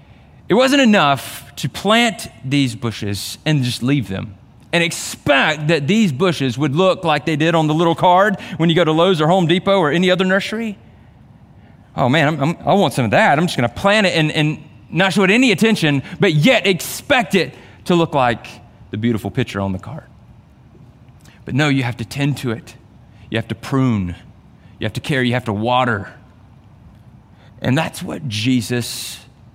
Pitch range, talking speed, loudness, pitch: 115-175 Hz, 195 wpm, -16 LUFS, 135 Hz